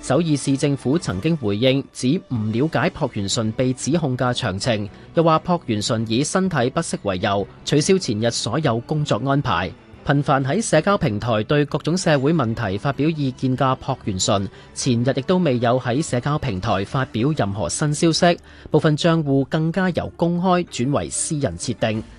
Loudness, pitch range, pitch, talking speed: -20 LUFS, 120-155 Hz, 135 Hz, 270 characters per minute